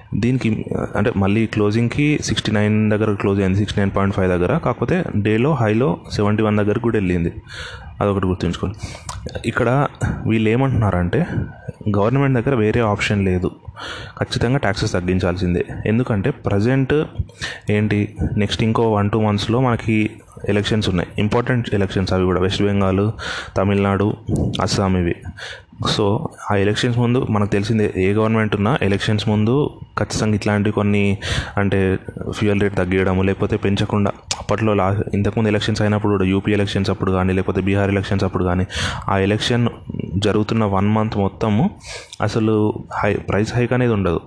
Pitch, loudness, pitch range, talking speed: 105 Hz, -19 LUFS, 100-110 Hz, 140 wpm